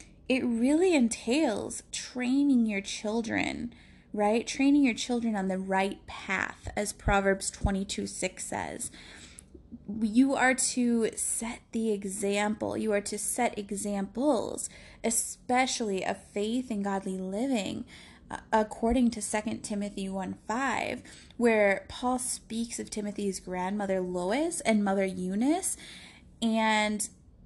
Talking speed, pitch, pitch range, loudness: 115 wpm, 220 Hz, 200-245 Hz, -29 LUFS